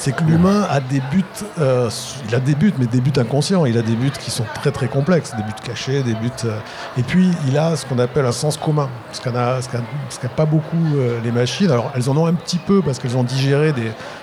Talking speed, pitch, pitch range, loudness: 255 wpm, 135 Hz, 125-155 Hz, -19 LUFS